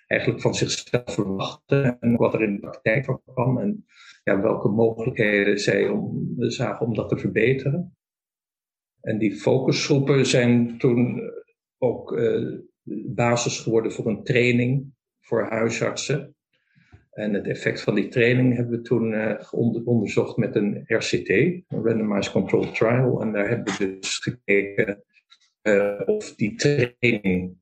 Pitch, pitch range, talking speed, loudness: 120 Hz, 105-130 Hz, 140 wpm, -23 LUFS